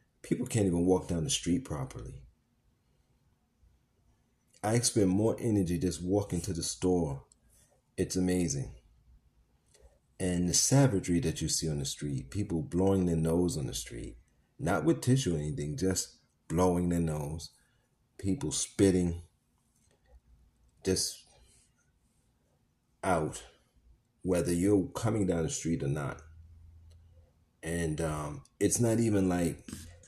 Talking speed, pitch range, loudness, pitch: 125 wpm, 80-95 Hz, -31 LUFS, 85 Hz